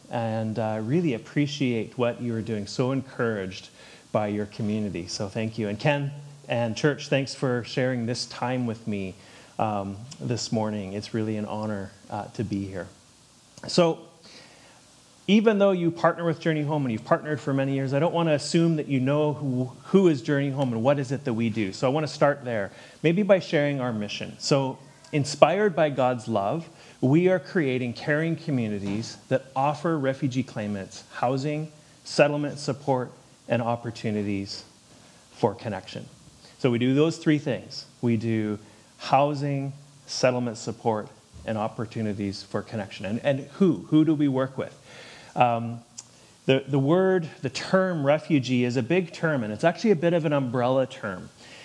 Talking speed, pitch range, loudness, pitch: 170 wpm, 110-150 Hz, -26 LUFS, 130 Hz